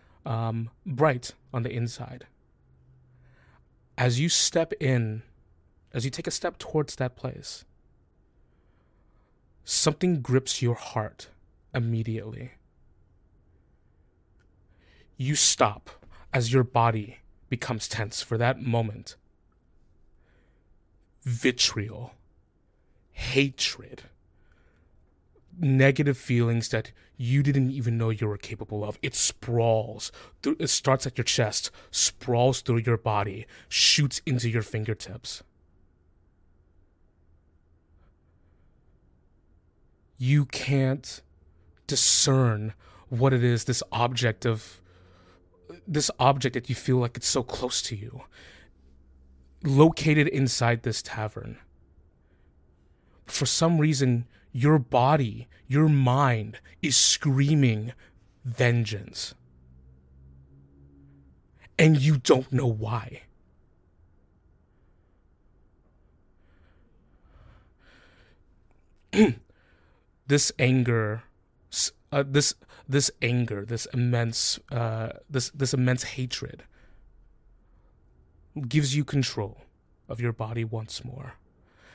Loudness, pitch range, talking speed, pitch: -25 LUFS, 85-130 Hz, 90 wpm, 115 Hz